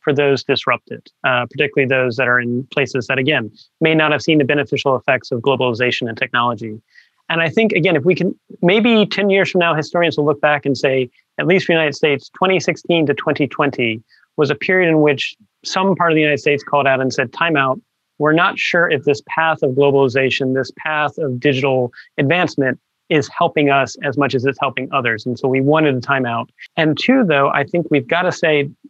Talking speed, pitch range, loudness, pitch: 220 wpm, 130-160 Hz, -16 LUFS, 145 Hz